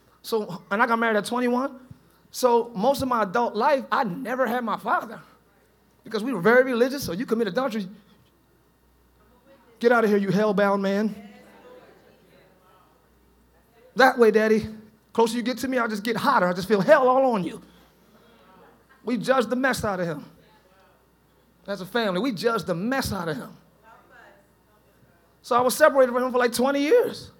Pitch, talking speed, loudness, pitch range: 235 Hz, 175 wpm, -23 LUFS, 210-255 Hz